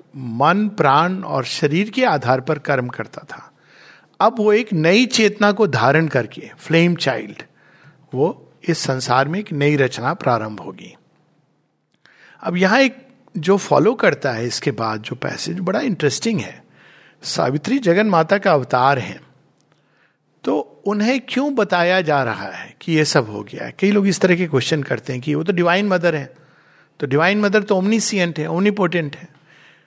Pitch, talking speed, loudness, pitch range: 170 Hz, 170 wpm, -18 LUFS, 140-205 Hz